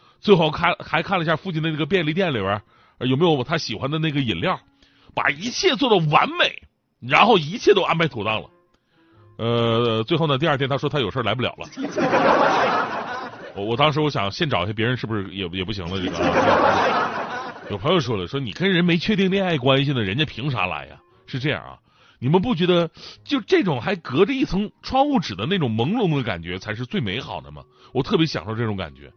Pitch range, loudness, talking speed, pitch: 110-175 Hz, -21 LUFS, 310 characters per minute, 145 Hz